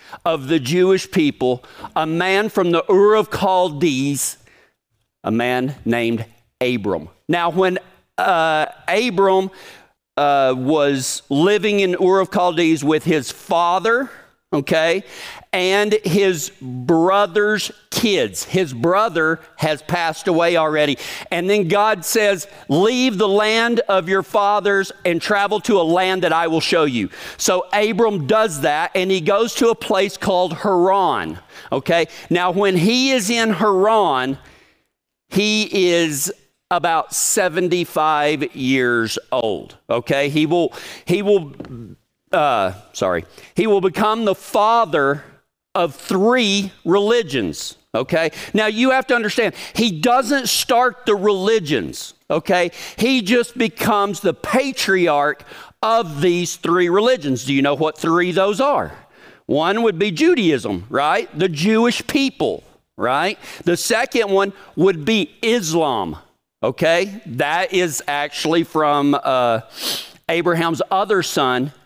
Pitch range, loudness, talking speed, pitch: 155-210 Hz, -18 LUFS, 125 wpm, 185 Hz